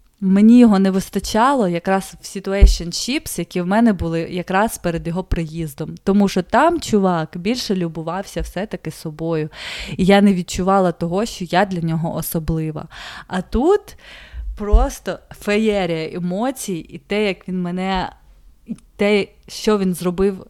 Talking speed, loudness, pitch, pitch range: 145 wpm, -19 LUFS, 190 Hz, 170-205 Hz